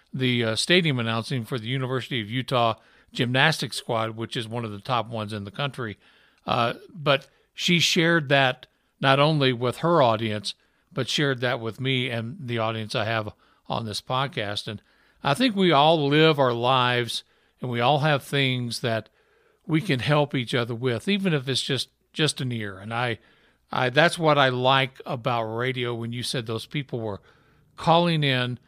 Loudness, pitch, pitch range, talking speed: -24 LUFS, 130 Hz, 115-145 Hz, 185 wpm